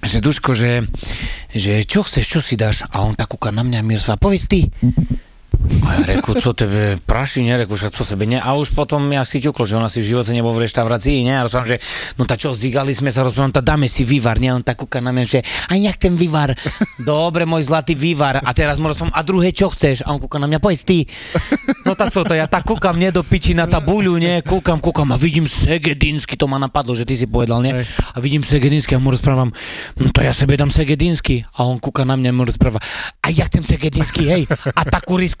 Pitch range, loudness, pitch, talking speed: 120-155 Hz, -16 LUFS, 135 Hz, 235 wpm